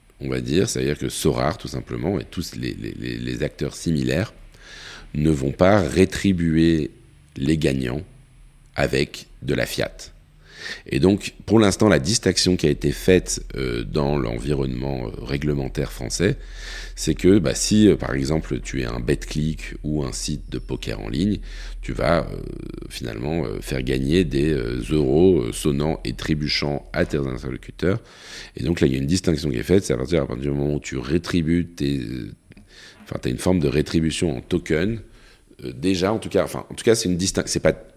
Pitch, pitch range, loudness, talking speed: 75 Hz, 70-90 Hz, -22 LUFS, 185 wpm